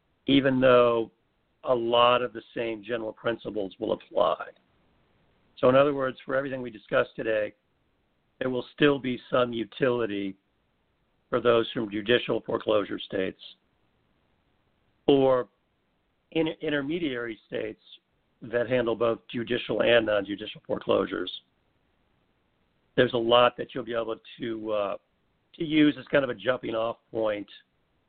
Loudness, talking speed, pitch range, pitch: -27 LUFS, 130 wpm, 110-130 Hz, 120 Hz